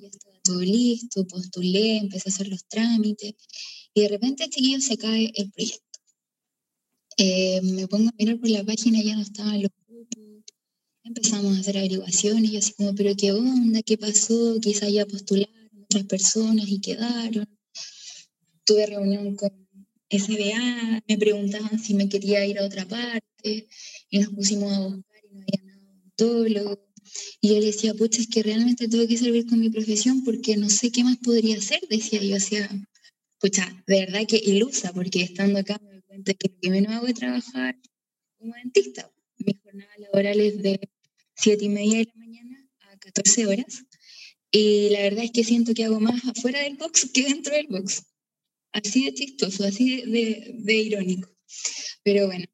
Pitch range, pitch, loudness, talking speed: 200-230 Hz, 210 Hz, -23 LUFS, 180 wpm